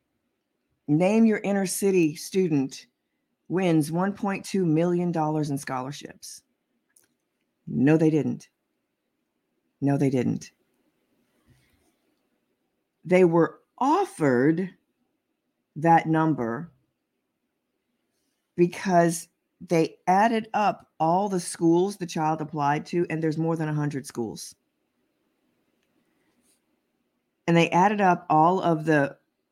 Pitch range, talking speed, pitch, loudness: 155-185 Hz, 95 wpm, 165 Hz, -24 LUFS